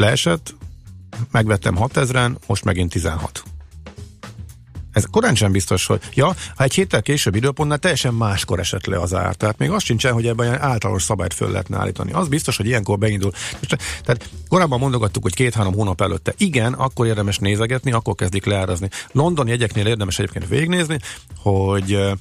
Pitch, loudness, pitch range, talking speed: 110 Hz, -19 LUFS, 95-125 Hz, 170 wpm